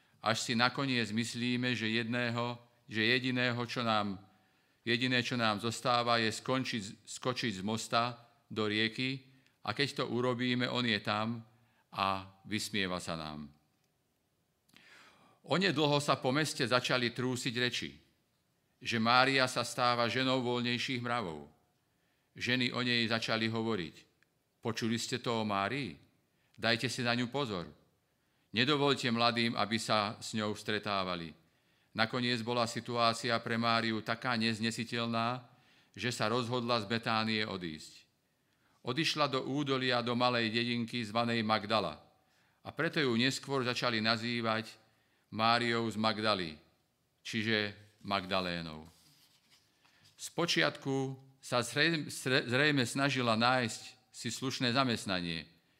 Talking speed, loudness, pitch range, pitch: 115 wpm, -33 LUFS, 110-125 Hz, 120 Hz